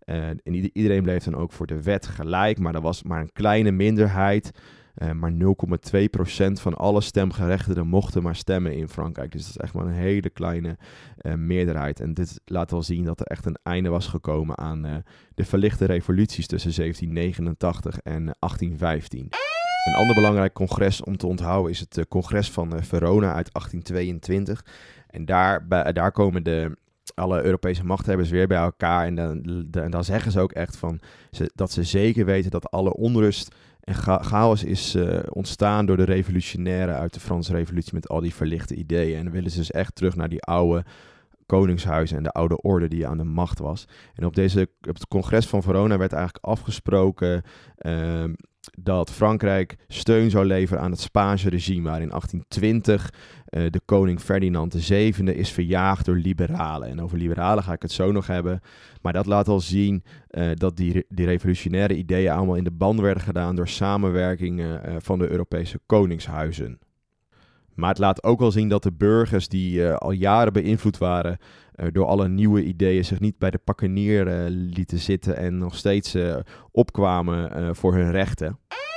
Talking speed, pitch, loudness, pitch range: 190 wpm, 90 Hz, -23 LUFS, 85-100 Hz